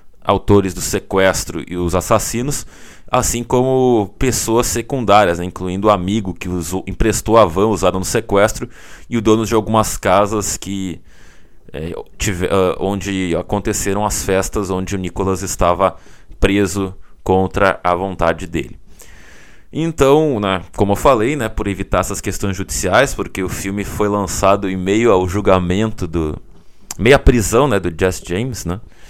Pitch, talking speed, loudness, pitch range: 100 Hz, 150 wpm, -16 LUFS, 95-110 Hz